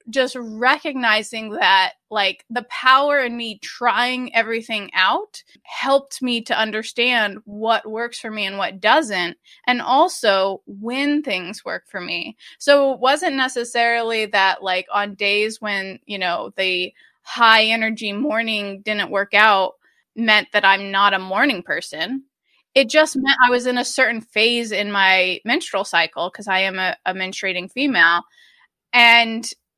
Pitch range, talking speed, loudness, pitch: 200-255 Hz, 150 wpm, -18 LUFS, 225 Hz